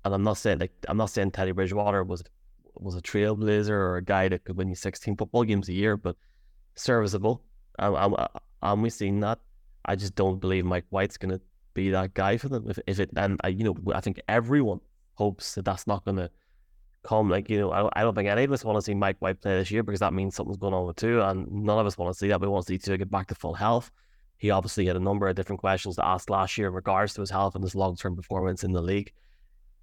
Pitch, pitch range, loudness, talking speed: 100 Hz, 95-105 Hz, -28 LUFS, 265 wpm